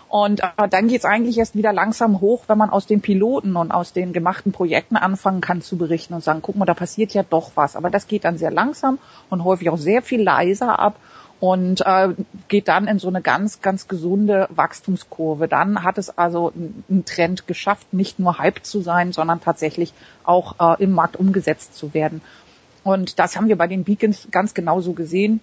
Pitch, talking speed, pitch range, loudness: 190 Hz, 210 wpm, 175-210 Hz, -19 LUFS